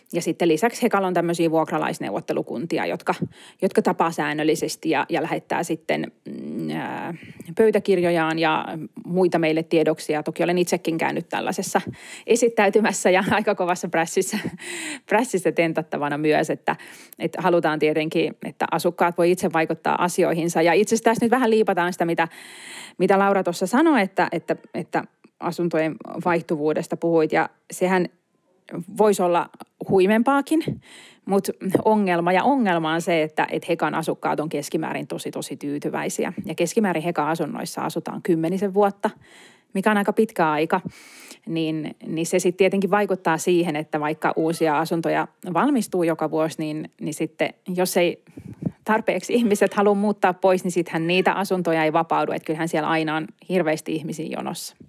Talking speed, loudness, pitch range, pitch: 140 wpm, -22 LUFS, 160-200 Hz, 175 Hz